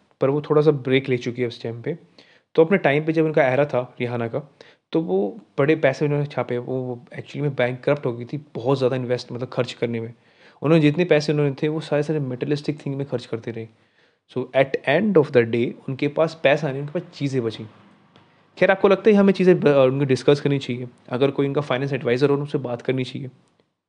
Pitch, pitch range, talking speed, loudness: 140 Hz, 125-150 Hz, 230 wpm, -21 LUFS